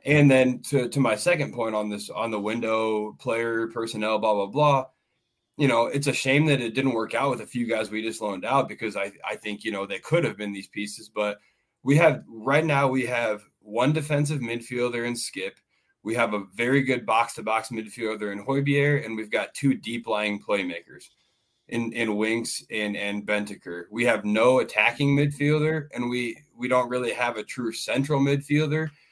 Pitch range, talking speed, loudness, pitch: 110-140 Hz, 200 wpm, -25 LUFS, 120 Hz